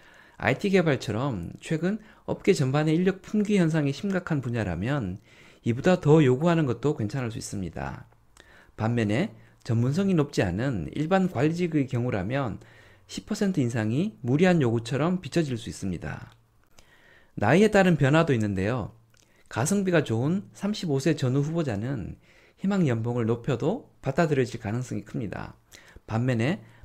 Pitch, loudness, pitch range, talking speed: 140 Hz, -26 LUFS, 115-170 Hz, 295 characters per minute